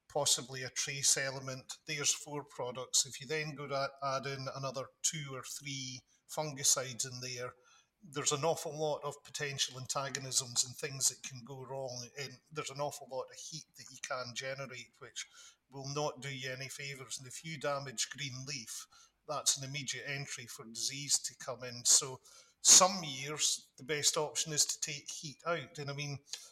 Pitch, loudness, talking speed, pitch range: 140 Hz, -34 LUFS, 185 wpm, 130-150 Hz